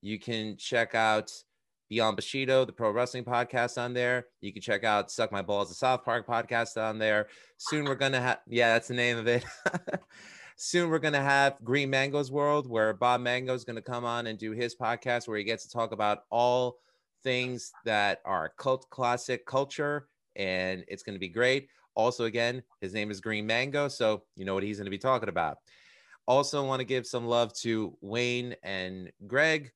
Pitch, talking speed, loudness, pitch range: 120 Hz, 195 wpm, -30 LUFS, 110-130 Hz